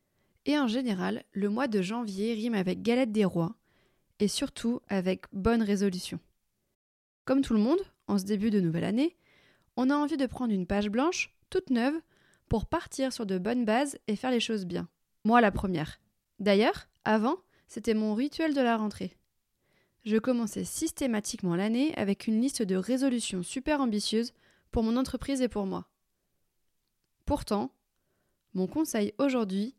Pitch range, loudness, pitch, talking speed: 205-265 Hz, -30 LUFS, 230 Hz, 160 wpm